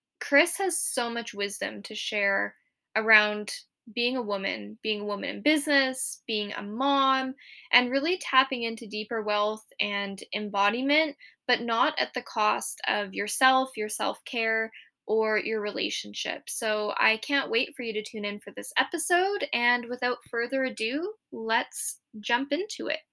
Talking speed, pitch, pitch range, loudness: 155 wpm, 230 Hz, 210-265 Hz, -27 LUFS